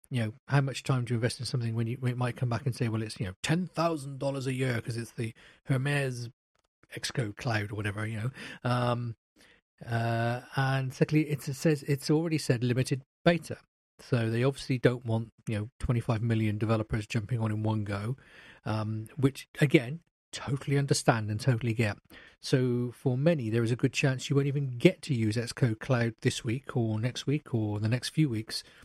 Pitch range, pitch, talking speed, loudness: 115-140 Hz, 125 Hz, 200 wpm, -30 LUFS